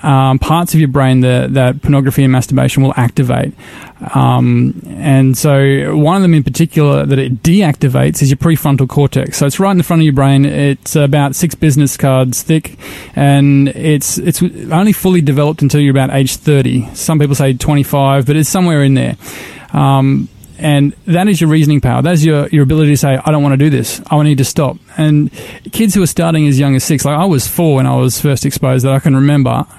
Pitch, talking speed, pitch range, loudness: 145 Hz, 220 wpm, 135-155 Hz, -11 LUFS